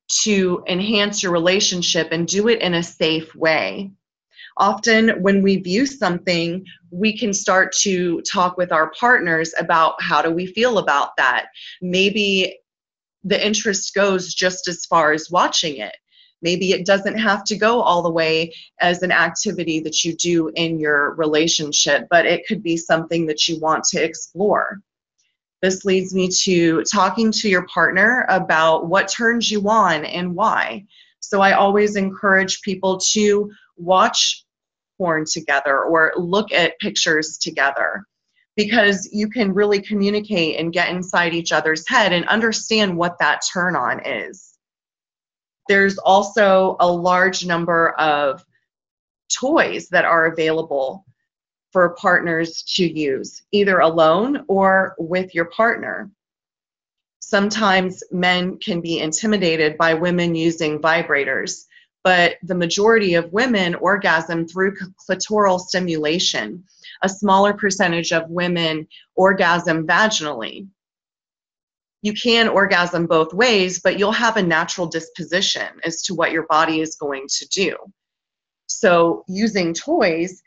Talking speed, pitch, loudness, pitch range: 135 wpm, 180 Hz, -18 LUFS, 165-200 Hz